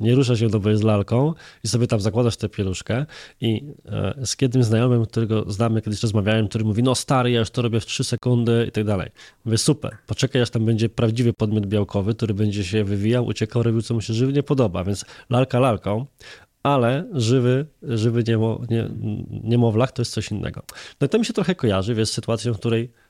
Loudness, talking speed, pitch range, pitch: -22 LUFS, 205 wpm, 110-125 Hz, 115 Hz